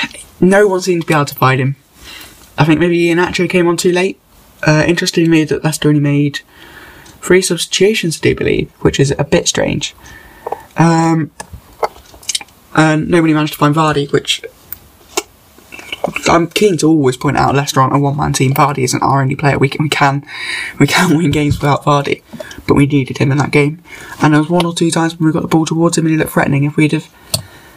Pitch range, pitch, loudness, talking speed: 145-170 Hz, 155 Hz, -13 LUFS, 205 wpm